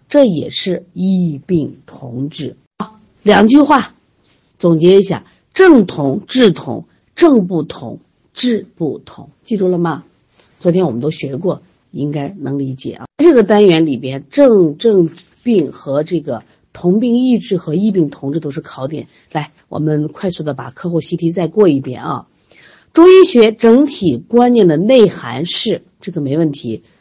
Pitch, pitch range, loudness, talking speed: 175 Hz, 150-215 Hz, -13 LUFS, 220 characters per minute